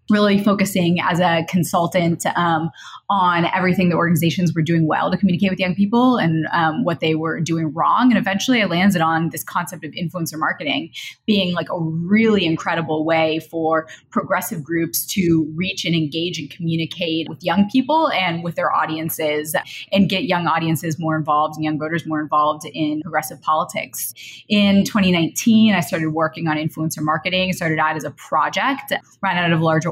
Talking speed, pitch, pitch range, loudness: 180 wpm, 170 Hz, 160-185 Hz, -19 LUFS